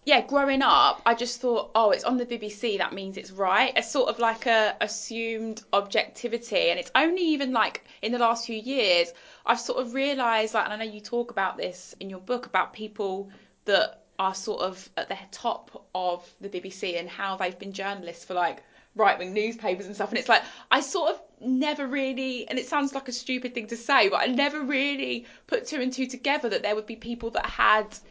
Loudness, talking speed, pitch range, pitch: -26 LUFS, 220 wpm, 200-260 Hz, 230 Hz